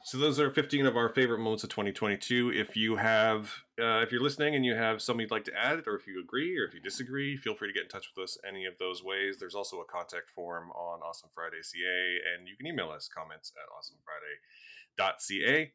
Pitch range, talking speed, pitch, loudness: 95-140 Hz, 245 wpm, 110 Hz, -32 LUFS